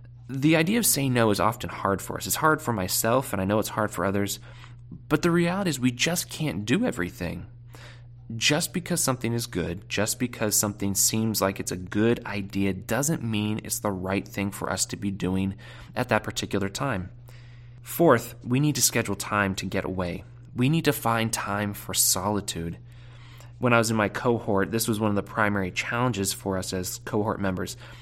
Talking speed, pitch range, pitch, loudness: 200 wpm, 100-120 Hz, 115 Hz, -25 LUFS